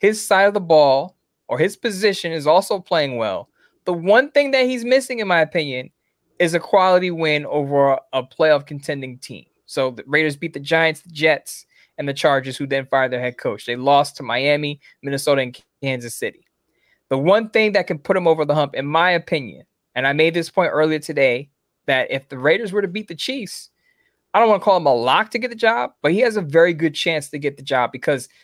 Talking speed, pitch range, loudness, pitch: 230 wpm, 140-195 Hz, -19 LUFS, 160 Hz